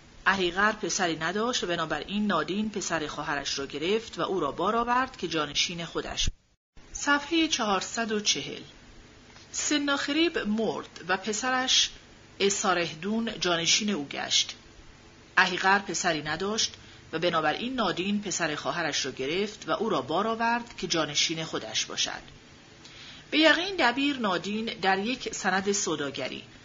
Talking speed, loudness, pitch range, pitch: 125 wpm, -27 LUFS, 160-225 Hz, 190 Hz